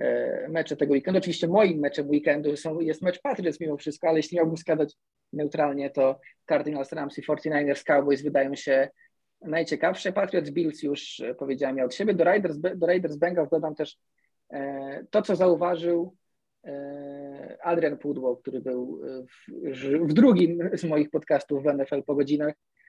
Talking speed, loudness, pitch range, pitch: 160 wpm, -26 LUFS, 140-170 Hz, 150 Hz